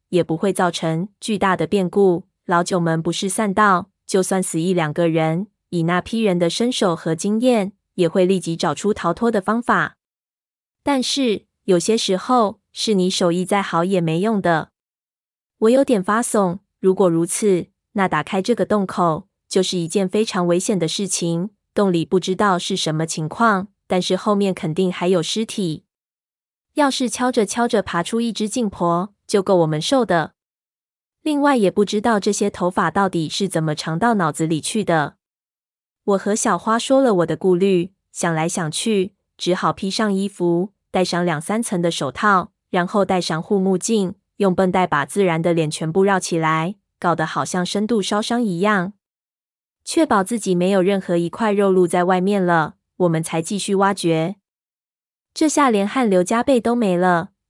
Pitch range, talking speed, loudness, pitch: 170-210 Hz, 250 characters per minute, -19 LUFS, 190 Hz